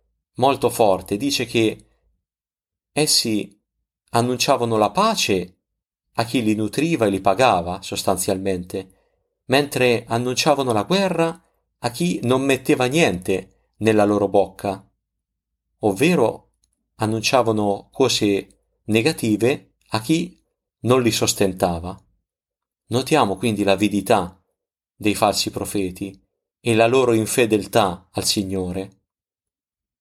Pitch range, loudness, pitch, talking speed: 95-125 Hz, -20 LUFS, 110 Hz, 100 wpm